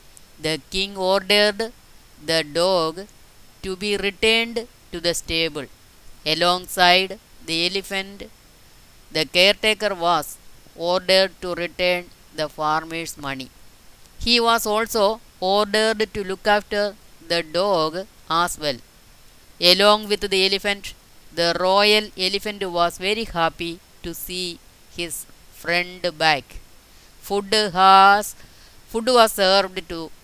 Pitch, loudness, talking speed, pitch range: 185 Hz, -20 LUFS, 110 wpm, 165-205 Hz